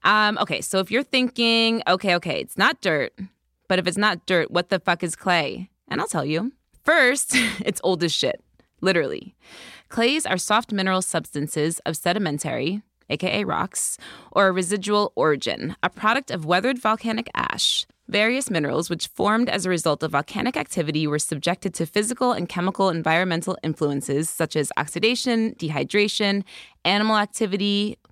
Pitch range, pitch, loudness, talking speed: 165-215 Hz, 190 Hz, -22 LUFS, 160 wpm